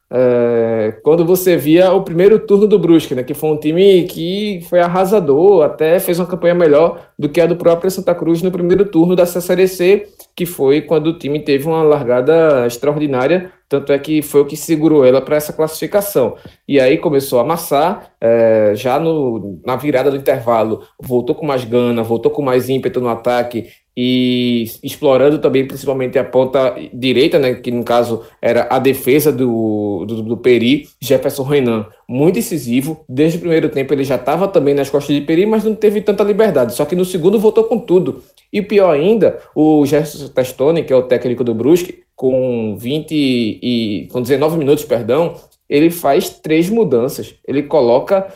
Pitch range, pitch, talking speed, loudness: 125-180 Hz, 150 Hz, 180 wpm, -14 LUFS